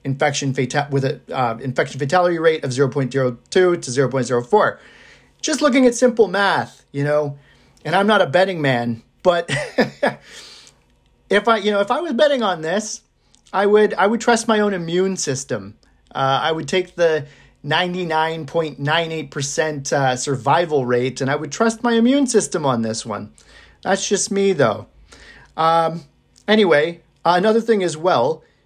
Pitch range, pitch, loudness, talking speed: 140-200 Hz, 160 Hz, -18 LUFS, 180 wpm